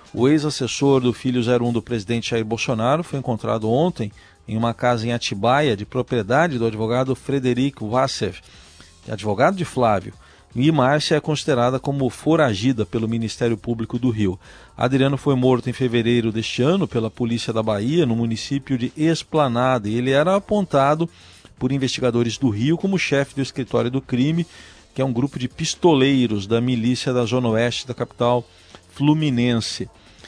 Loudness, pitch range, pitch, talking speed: -20 LUFS, 115-140 Hz, 125 Hz, 160 wpm